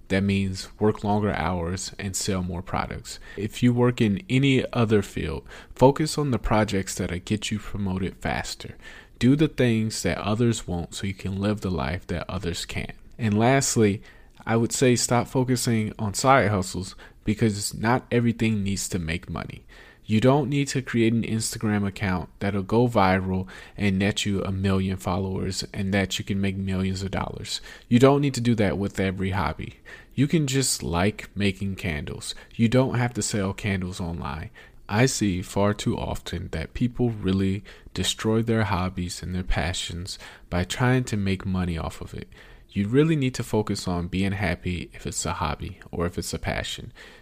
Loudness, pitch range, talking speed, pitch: -25 LUFS, 95-115 Hz, 180 wpm, 100 Hz